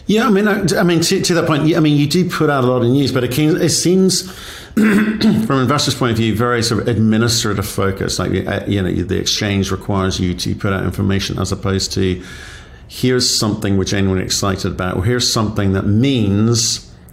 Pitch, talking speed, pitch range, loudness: 115 Hz, 215 wpm, 95-150 Hz, -15 LUFS